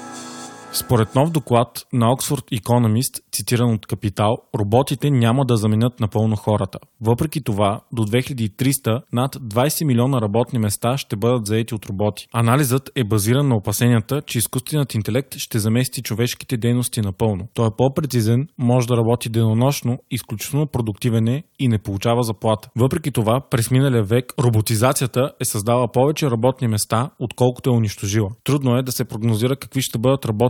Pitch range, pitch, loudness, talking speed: 110-130 Hz, 120 Hz, -20 LUFS, 155 wpm